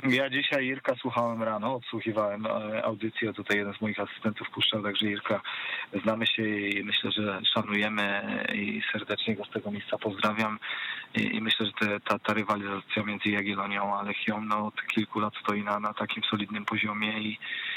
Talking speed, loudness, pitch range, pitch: 170 wpm, -29 LUFS, 105-110 Hz, 105 Hz